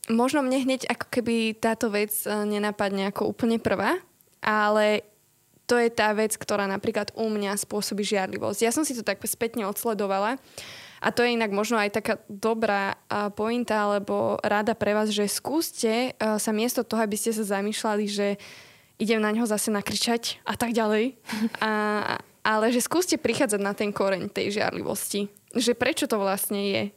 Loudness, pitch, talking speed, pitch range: -26 LUFS, 215 Hz, 165 wpm, 205-230 Hz